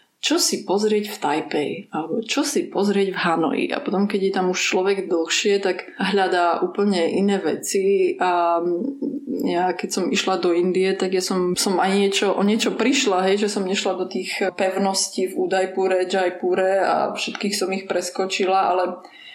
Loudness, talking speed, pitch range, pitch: -21 LUFS, 175 wpm, 185-205 Hz, 190 Hz